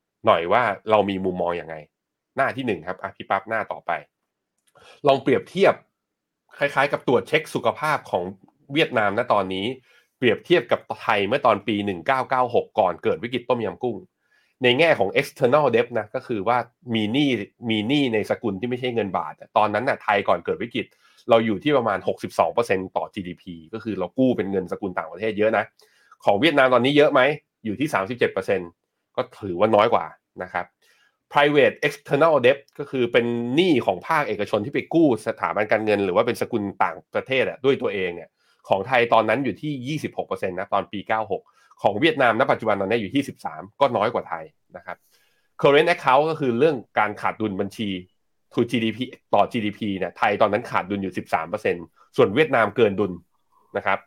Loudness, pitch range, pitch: -22 LUFS, 100-125 Hz, 110 Hz